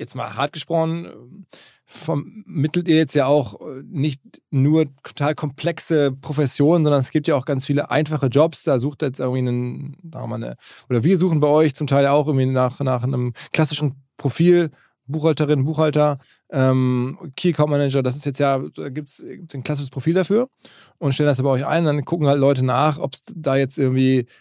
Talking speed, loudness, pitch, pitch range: 190 wpm, -20 LUFS, 145 Hz, 135-155 Hz